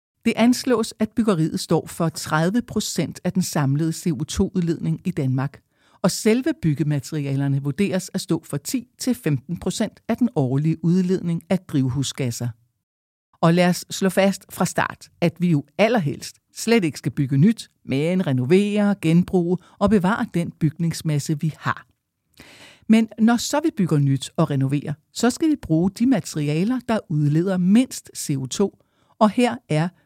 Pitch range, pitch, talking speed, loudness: 150-210 Hz, 175 Hz, 150 wpm, -22 LUFS